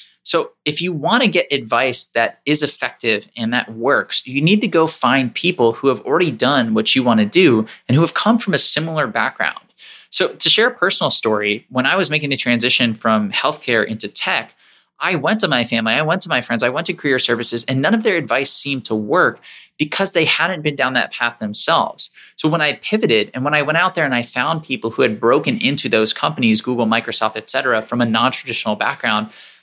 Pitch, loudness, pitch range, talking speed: 135 Hz, -17 LUFS, 115-165 Hz, 225 wpm